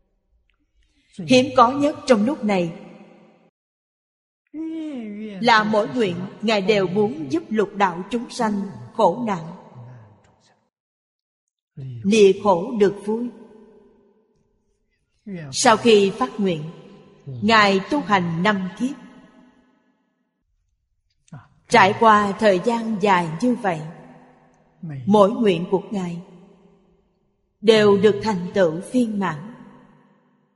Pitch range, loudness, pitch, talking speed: 185-225 Hz, -19 LUFS, 205 Hz, 95 wpm